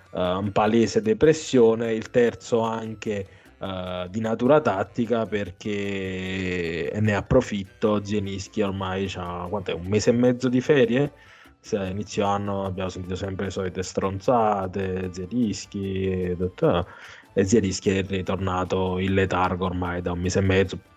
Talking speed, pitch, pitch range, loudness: 130 wpm, 100 Hz, 95-110 Hz, -24 LUFS